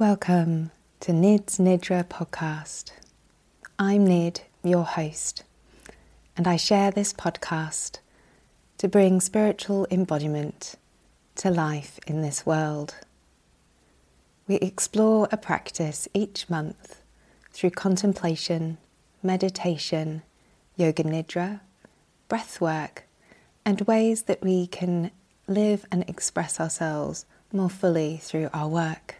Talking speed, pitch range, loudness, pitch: 105 wpm, 160-195 Hz, -25 LUFS, 175 Hz